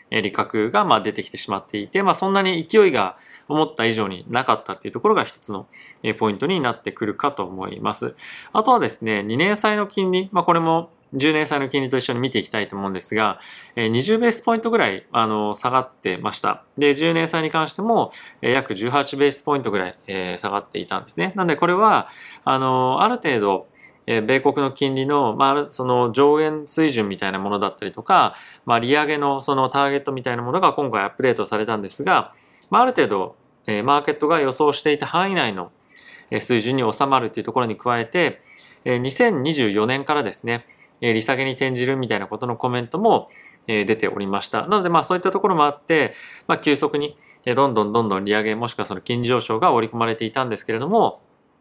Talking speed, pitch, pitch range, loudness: 400 characters per minute, 135 Hz, 115-155 Hz, -20 LUFS